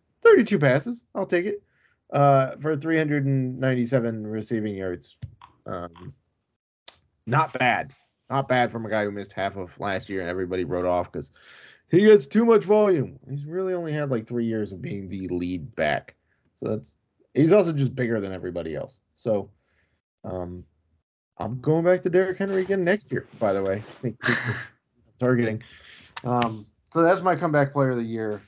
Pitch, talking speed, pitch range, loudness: 120 Hz, 165 wpm, 100-160 Hz, -24 LUFS